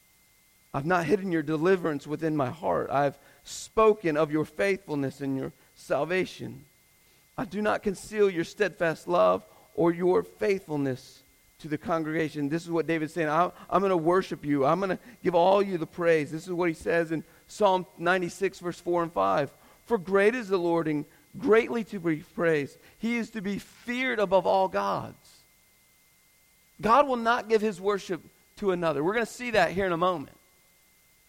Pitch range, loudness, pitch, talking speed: 160-200 Hz, -27 LUFS, 175 Hz, 180 wpm